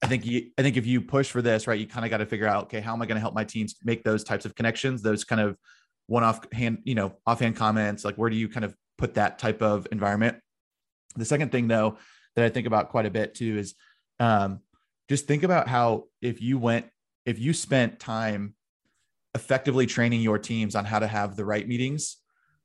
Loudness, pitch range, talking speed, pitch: -26 LUFS, 105-120 Hz, 235 wpm, 115 Hz